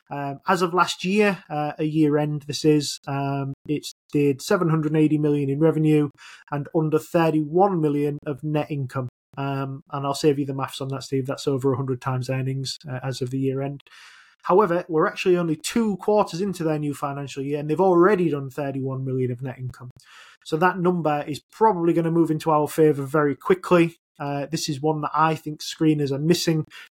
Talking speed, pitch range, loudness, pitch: 200 wpm, 140-165 Hz, -23 LUFS, 150 Hz